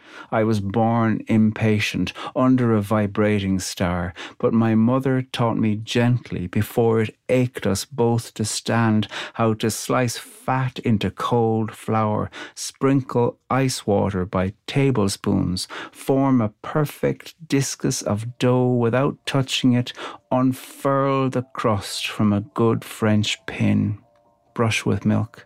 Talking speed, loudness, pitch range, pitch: 125 wpm, -22 LUFS, 105-125 Hz, 115 Hz